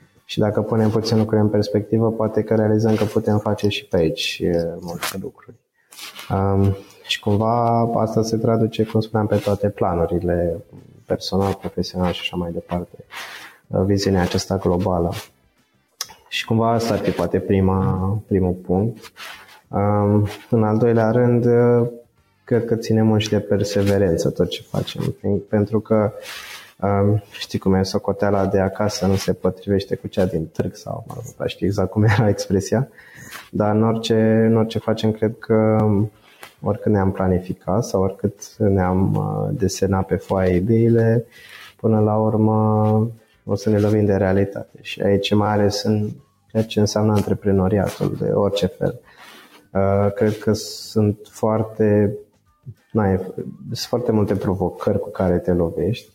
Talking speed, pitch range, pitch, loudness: 145 wpm, 95-110 Hz, 105 Hz, -20 LUFS